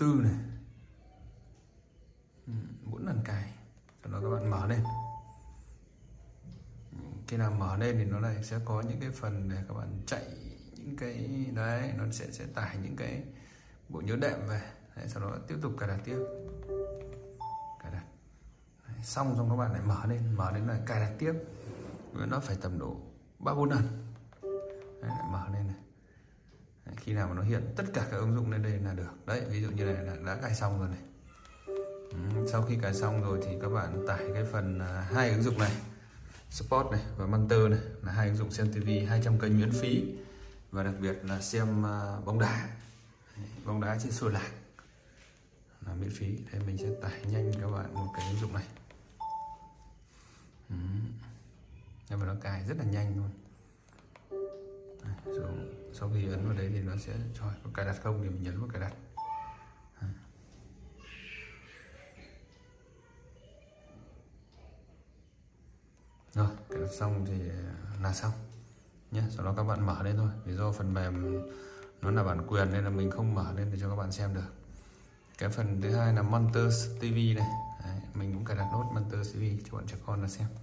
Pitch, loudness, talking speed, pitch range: 105 Hz, -34 LUFS, 180 wpm, 100-115 Hz